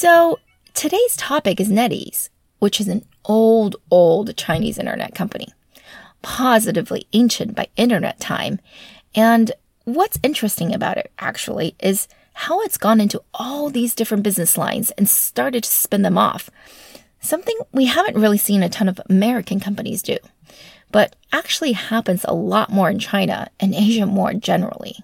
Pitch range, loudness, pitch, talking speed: 200-245 Hz, -18 LUFS, 220 Hz, 150 wpm